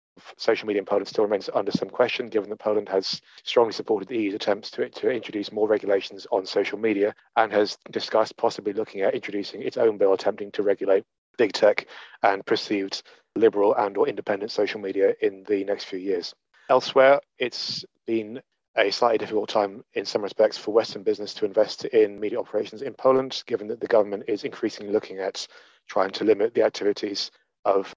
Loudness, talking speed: -25 LUFS, 190 wpm